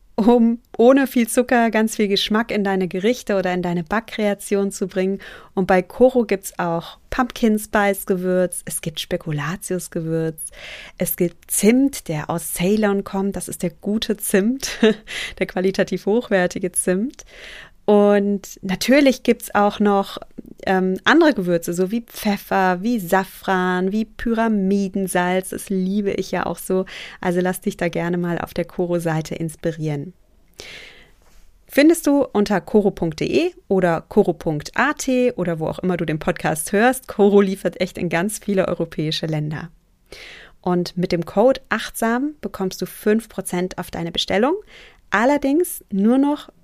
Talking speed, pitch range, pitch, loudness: 140 wpm, 180-225 Hz, 195 Hz, -20 LUFS